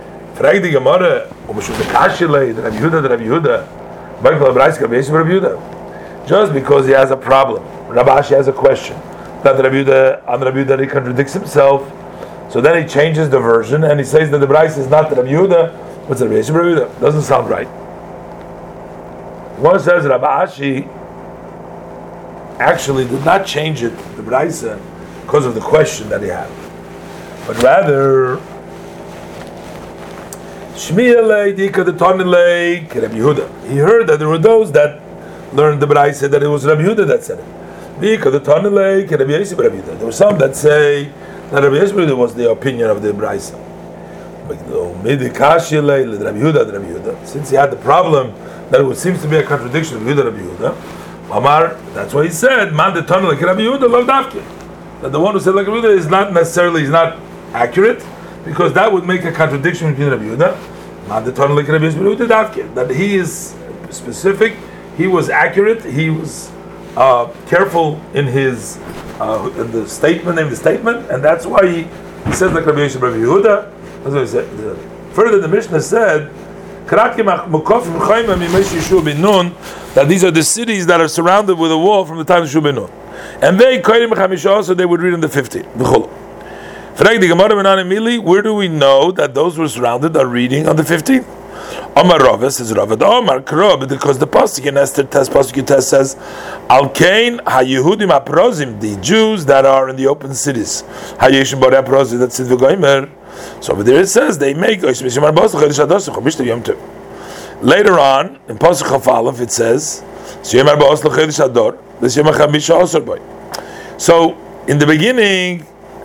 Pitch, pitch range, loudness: 165 Hz, 140-195 Hz, -12 LUFS